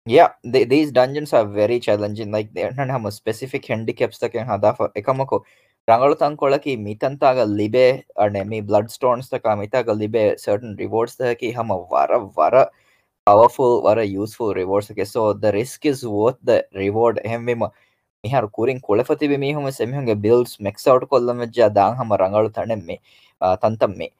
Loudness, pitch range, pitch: -19 LUFS, 105-135 Hz, 115 Hz